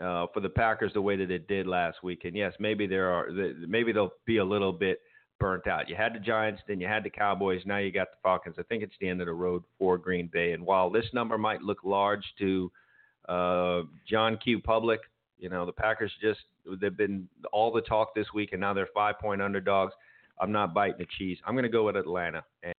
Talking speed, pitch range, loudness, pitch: 240 wpm, 90-105 Hz, -30 LUFS, 100 Hz